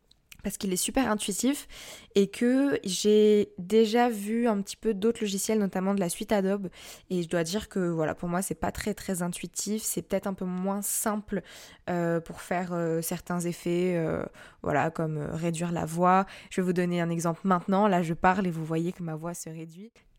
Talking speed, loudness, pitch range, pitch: 210 wpm, -28 LUFS, 175-210 Hz, 185 Hz